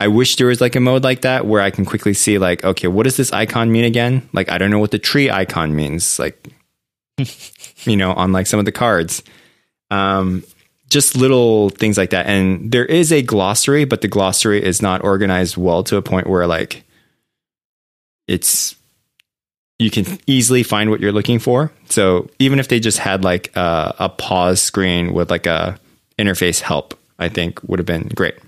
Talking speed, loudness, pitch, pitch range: 200 wpm, -15 LUFS, 105 Hz, 95-125 Hz